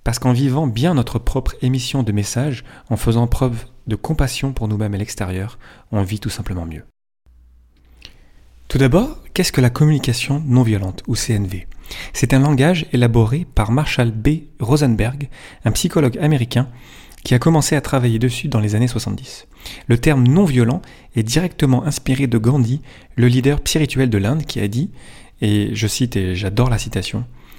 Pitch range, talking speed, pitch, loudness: 110-135 Hz, 165 wpm, 125 Hz, -18 LUFS